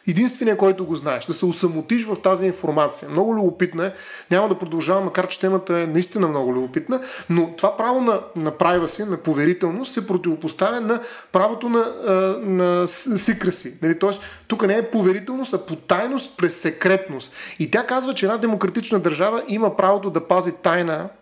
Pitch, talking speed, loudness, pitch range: 190 Hz, 170 wpm, -21 LUFS, 175-215 Hz